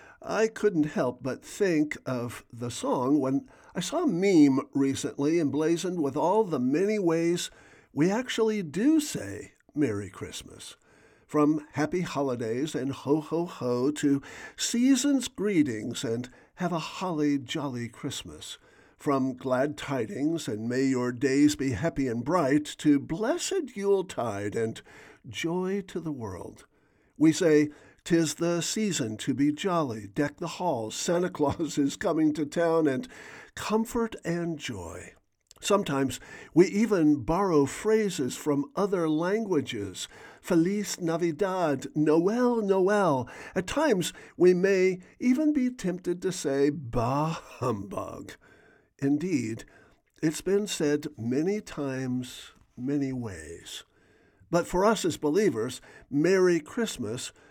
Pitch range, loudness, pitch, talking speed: 140-190 Hz, -28 LUFS, 155 Hz, 125 wpm